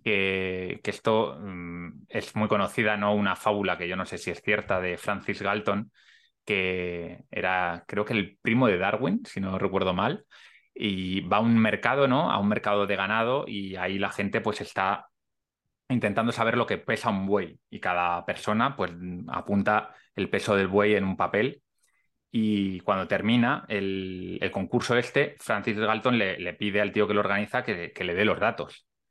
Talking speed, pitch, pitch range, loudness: 190 wpm, 100 Hz, 95-110 Hz, -27 LUFS